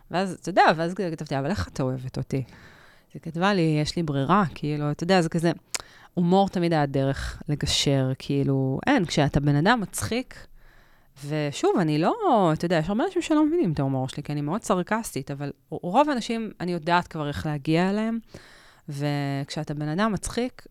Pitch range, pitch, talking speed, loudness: 145-190 Hz, 155 Hz, 180 wpm, -25 LUFS